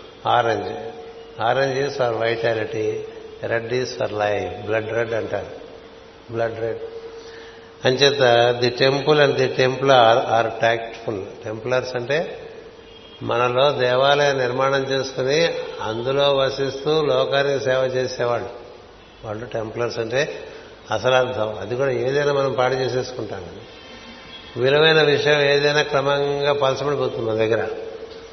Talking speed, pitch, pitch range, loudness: 105 wpm, 135 Hz, 120-145 Hz, -20 LUFS